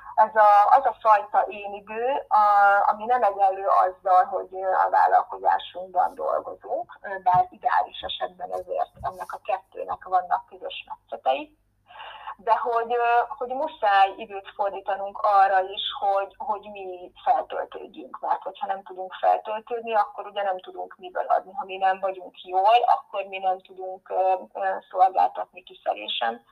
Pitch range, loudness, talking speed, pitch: 190-240 Hz, -24 LUFS, 135 wpm, 205 Hz